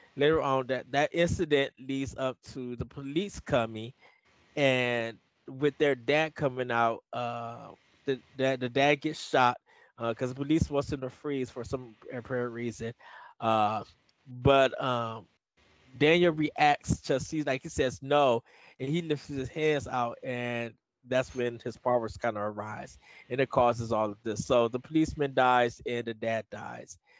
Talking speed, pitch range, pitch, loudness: 165 wpm, 120-140 Hz, 130 Hz, -29 LUFS